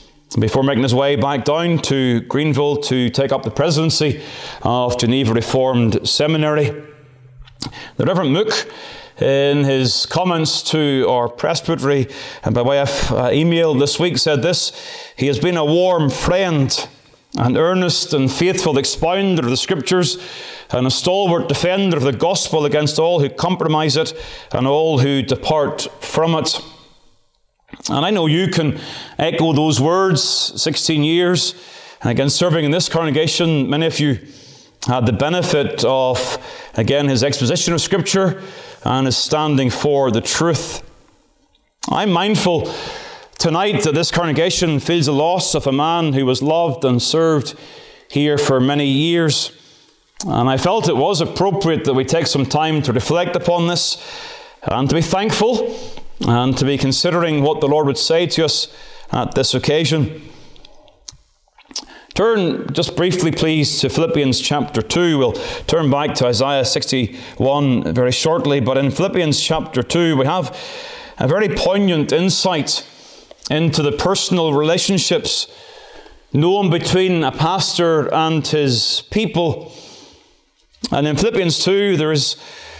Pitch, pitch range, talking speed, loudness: 155 Hz, 135-175 Hz, 145 wpm, -16 LUFS